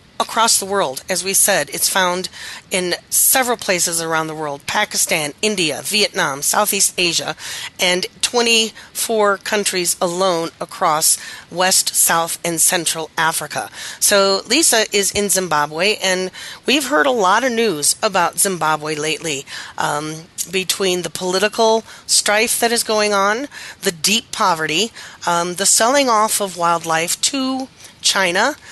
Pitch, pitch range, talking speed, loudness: 190 Hz, 170-215 Hz, 135 wpm, -16 LUFS